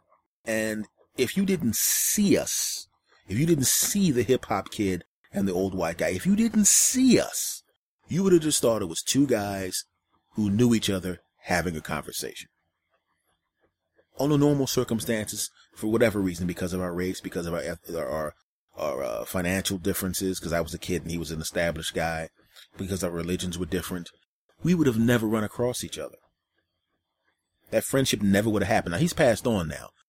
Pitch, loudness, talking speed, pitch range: 100 Hz, -26 LUFS, 185 wpm, 90-125 Hz